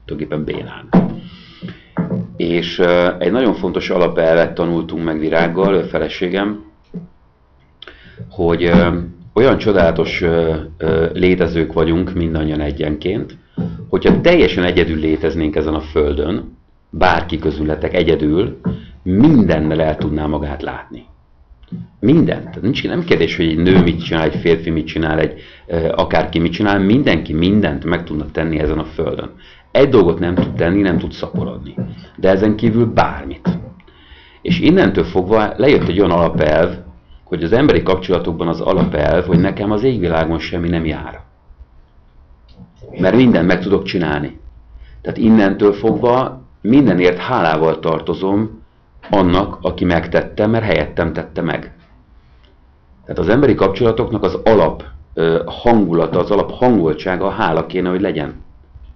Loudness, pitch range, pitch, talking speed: -15 LUFS, 75-90 Hz, 80 Hz, 130 wpm